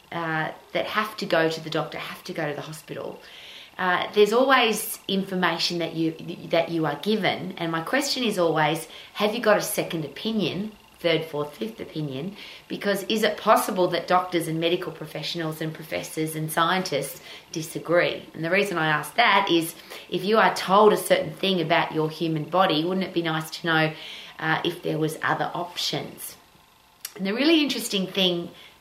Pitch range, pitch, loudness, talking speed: 160-195 Hz, 175 Hz, -24 LUFS, 185 wpm